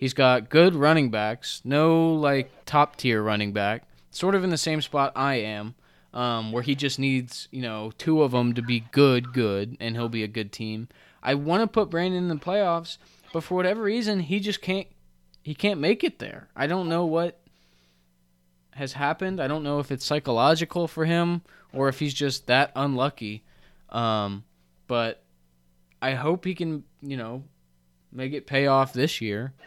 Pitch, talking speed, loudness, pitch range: 135 Hz, 190 wpm, -25 LUFS, 110-160 Hz